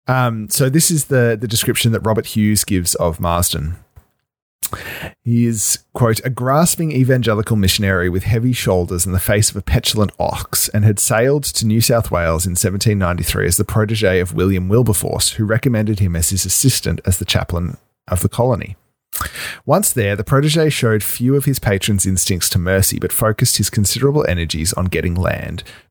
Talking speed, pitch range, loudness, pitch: 180 wpm, 95-125 Hz, -16 LUFS, 110 Hz